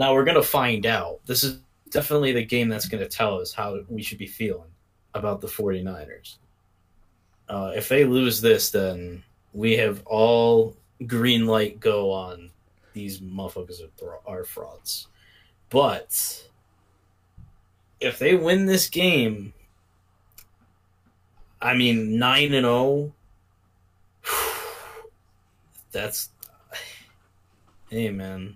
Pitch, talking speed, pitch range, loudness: 110 Hz, 120 wpm, 95-125 Hz, -23 LUFS